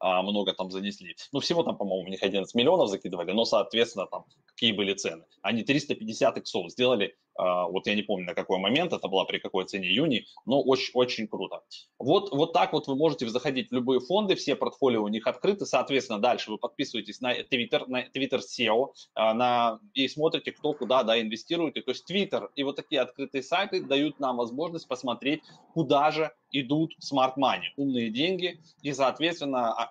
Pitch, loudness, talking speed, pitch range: 125 Hz, -28 LUFS, 180 wpm, 110-145 Hz